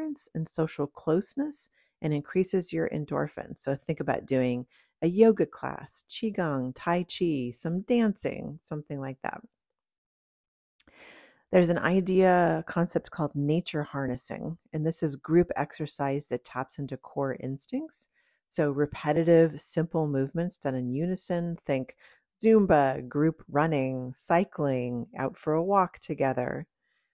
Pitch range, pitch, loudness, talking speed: 135-175 Hz, 155 Hz, -28 LUFS, 125 wpm